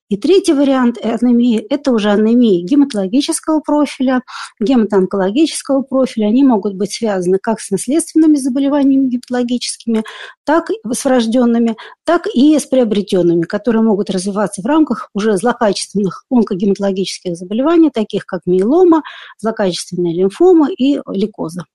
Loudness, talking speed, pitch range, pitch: -14 LUFS, 120 wpm, 200-280 Hz, 235 Hz